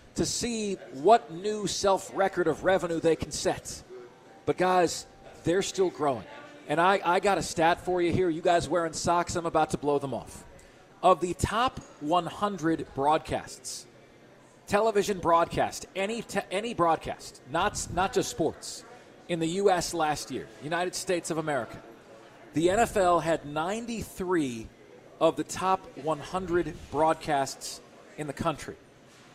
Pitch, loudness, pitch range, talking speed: 175 Hz, -28 LUFS, 155-190 Hz, 145 wpm